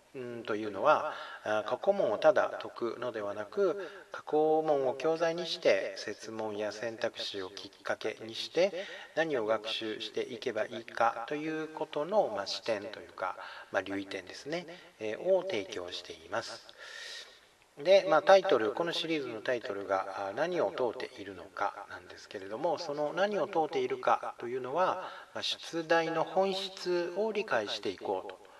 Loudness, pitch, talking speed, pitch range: -32 LUFS, 155 Hz, 315 characters per minute, 115-190 Hz